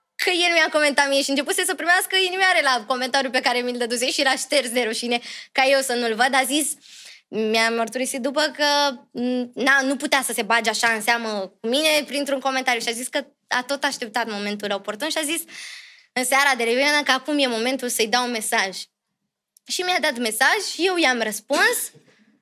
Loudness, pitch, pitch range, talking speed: -21 LUFS, 265 Hz, 240-295 Hz, 205 wpm